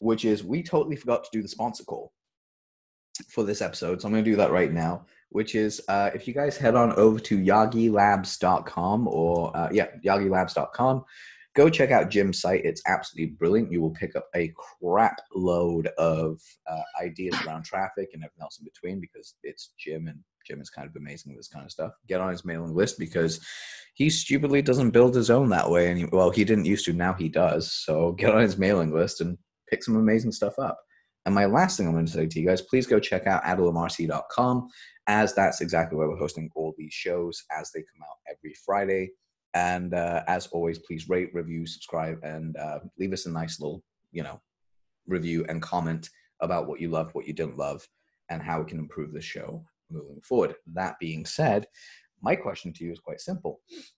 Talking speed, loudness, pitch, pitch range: 210 wpm, -26 LUFS, 90 Hz, 80-110 Hz